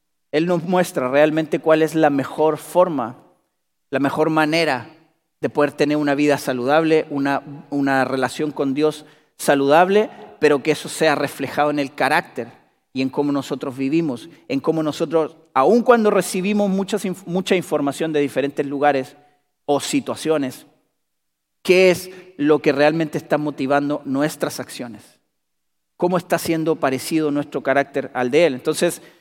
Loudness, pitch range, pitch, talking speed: -19 LUFS, 140-165 Hz, 150 Hz, 145 wpm